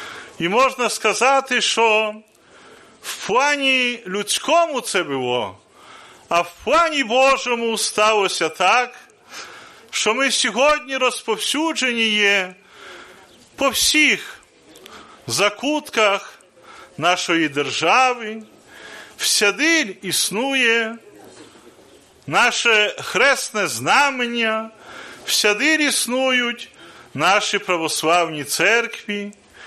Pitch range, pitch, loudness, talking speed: 205-270 Hz, 230 Hz, -18 LUFS, 70 wpm